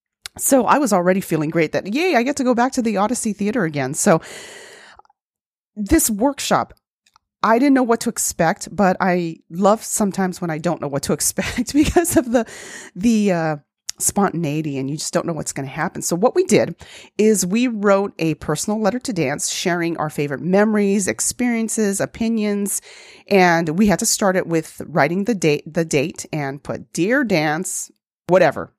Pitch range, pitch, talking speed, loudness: 165-235 Hz, 200 Hz, 185 wpm, -19 LUFS